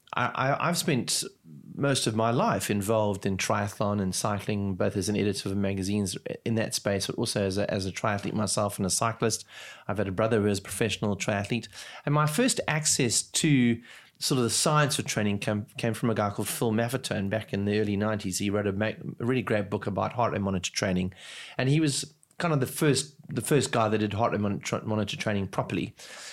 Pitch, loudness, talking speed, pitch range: 110 Hz, -28 LUFS, 215 wpm, 100-125 Hz